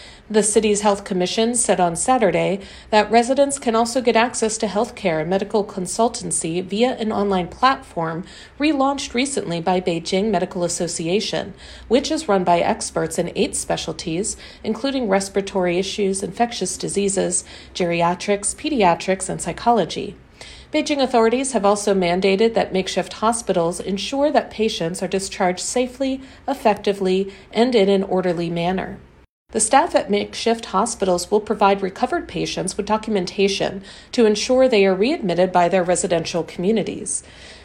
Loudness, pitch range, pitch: -20 LUFS, 185-230 Hz, 200 Hz